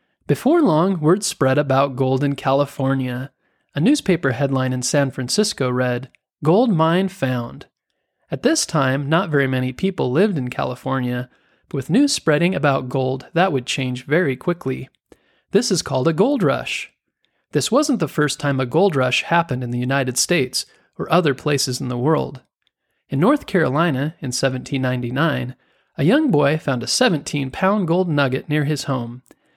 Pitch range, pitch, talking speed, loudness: 130-170 Hz, 140 Hz, 165 wpm, -19 LUFS